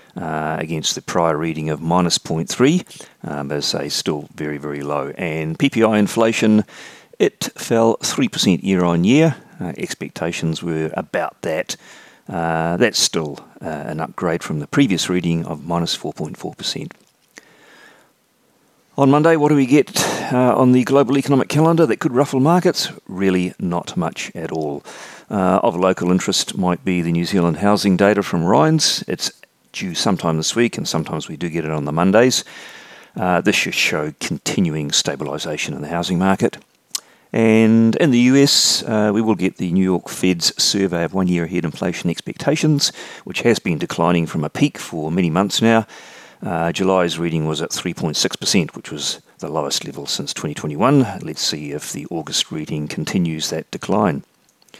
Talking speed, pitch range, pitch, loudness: 175 wpm, 80-115 Hz, 90 Hz, -18 LUFS